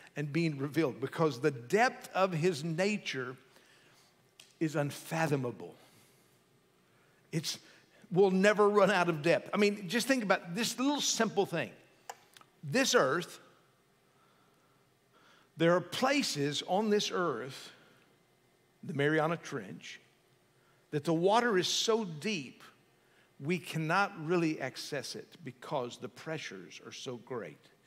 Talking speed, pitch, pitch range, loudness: 120 wpm, 170 Hz, 145-200 Hz, -32 LUFS